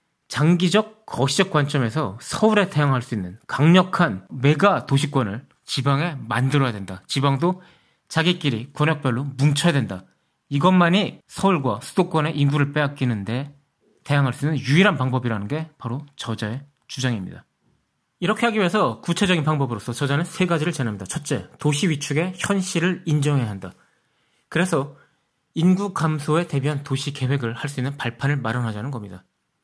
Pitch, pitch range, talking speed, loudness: 145 Hz, 130-170 Hz, 350 characters per minute, -22 LUFS